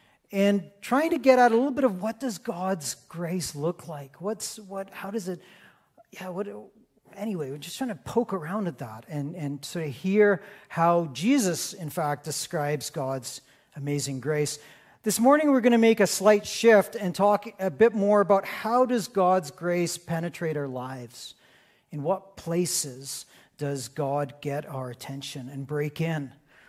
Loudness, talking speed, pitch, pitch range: -26 LUFS, 170 wpm, 175 Hz, 145-210 Hz